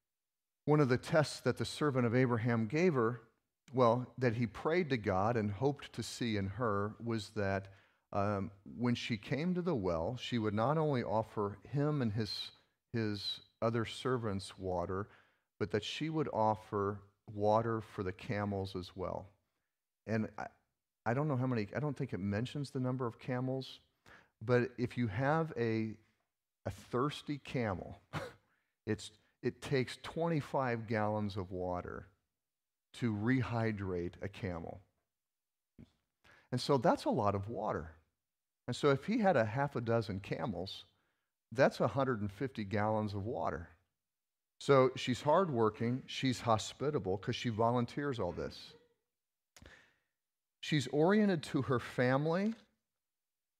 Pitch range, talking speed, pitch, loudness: 105-135 Hz, 140 wpm, 115 Hz, -36 LUFS